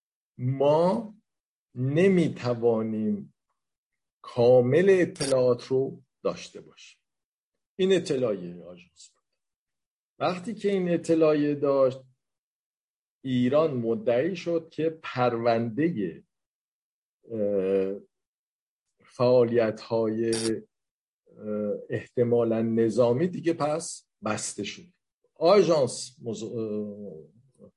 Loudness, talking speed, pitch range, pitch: -26 LUFS, 65 wpm, 115-160 Hz, 125 Hz